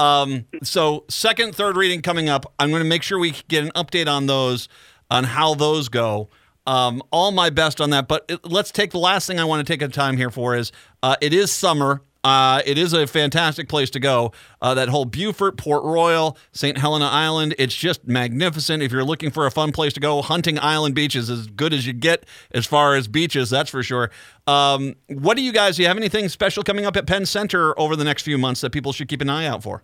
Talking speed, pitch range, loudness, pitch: 245 wpm, 135-170 Hz, -19 LUFS, 150 Hz